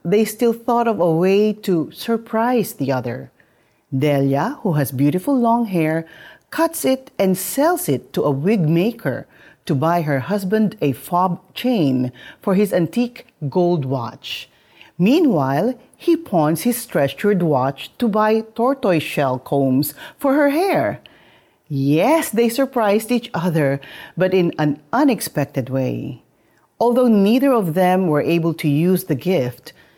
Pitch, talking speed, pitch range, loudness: 180 Hz, 140 wpm, 145-235 Hz, -19 LUFS